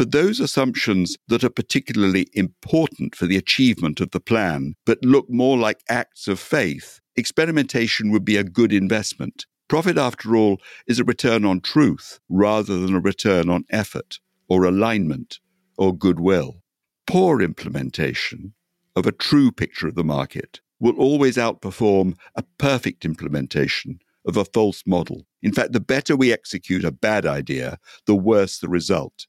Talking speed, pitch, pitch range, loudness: 155 wpm, 100 Hz, 90-120 Hz, -20 LUFS